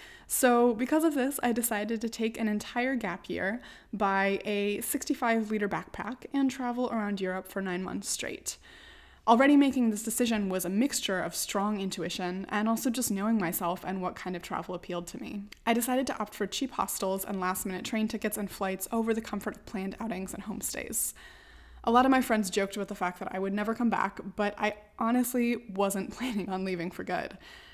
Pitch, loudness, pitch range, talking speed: 210 Hz, -30 LUFS, 195-240 Hz, 205 wpm